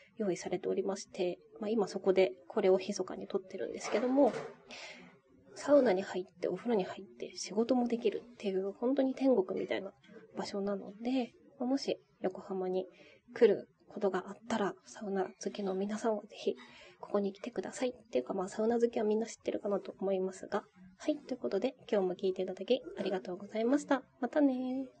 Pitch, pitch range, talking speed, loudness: 200 Hz, 190-240 Hz, 400 characters per minute, -35 LUFS